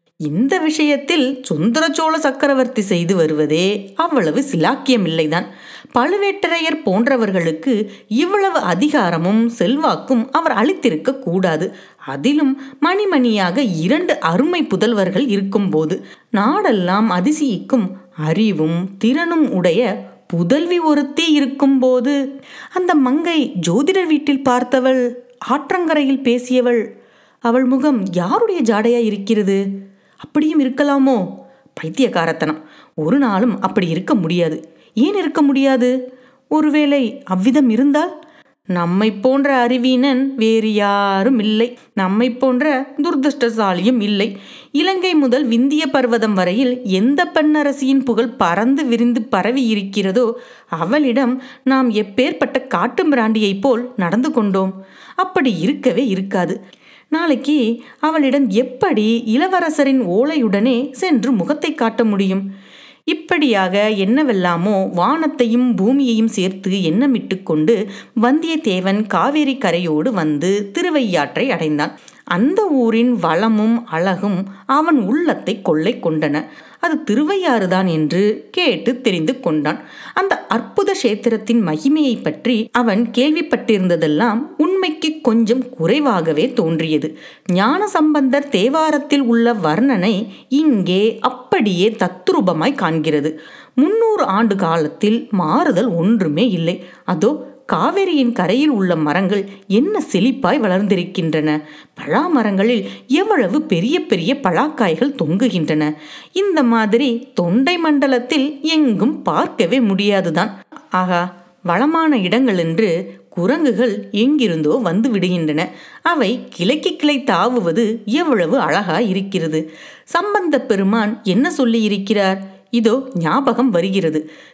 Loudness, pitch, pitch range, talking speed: -16 LUFS, 240 Hz, 195-280 Hz, 95 wpm